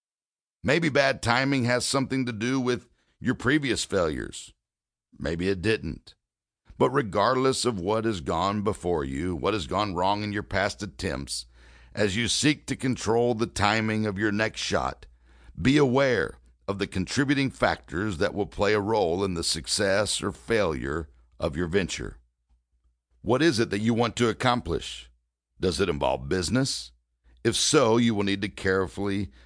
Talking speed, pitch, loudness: 160 wpm, 100 Hz, -26 LUFS